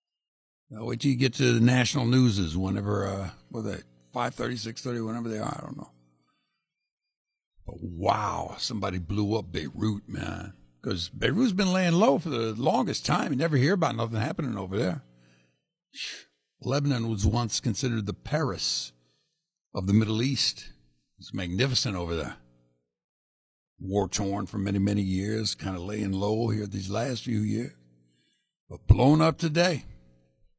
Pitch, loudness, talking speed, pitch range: 105 Hz, -27 LUFS, 160 wpm, 85-125 Hz